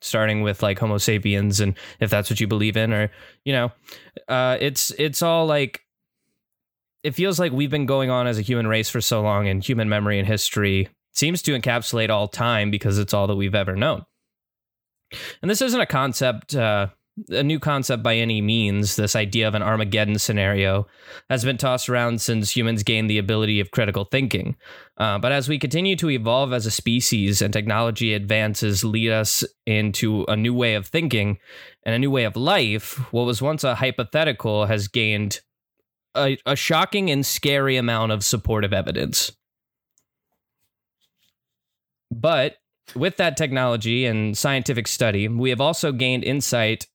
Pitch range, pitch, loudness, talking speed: 105-130 Hz, 115 Hz, -21 LUFS, 175 wpm